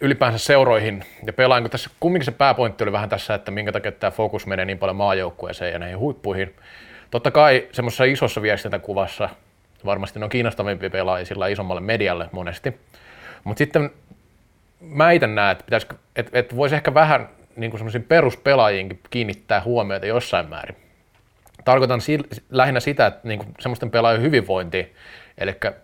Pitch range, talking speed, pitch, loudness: 95-130 Hz, 155 wpm, 110 Hz, -20 LUFS